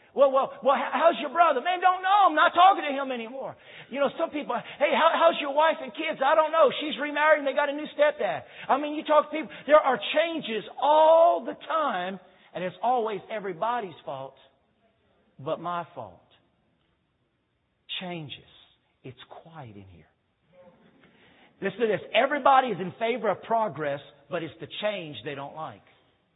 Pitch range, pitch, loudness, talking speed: 180-300 Hz, 255 Hz, -25 LUFS, 180 wpm